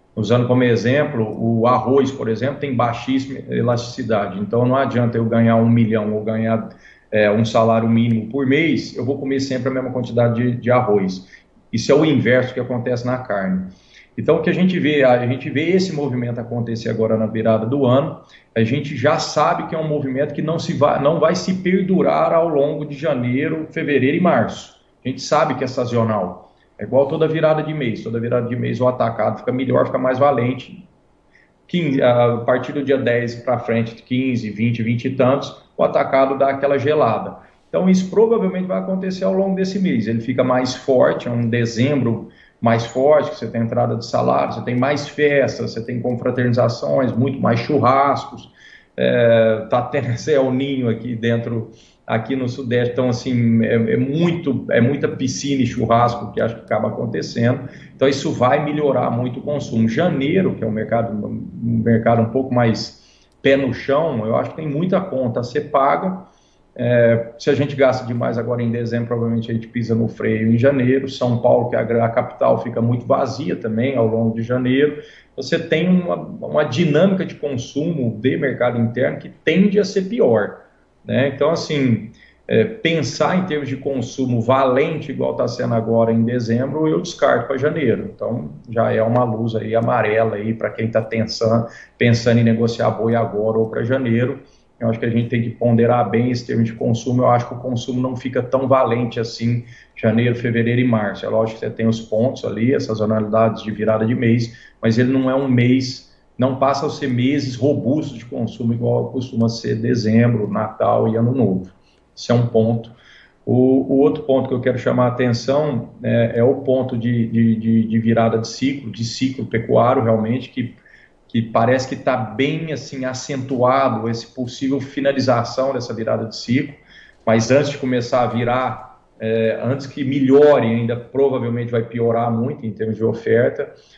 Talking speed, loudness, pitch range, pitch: 190 wpm, -18 LUFS, 115-135 Hz, 125 Hz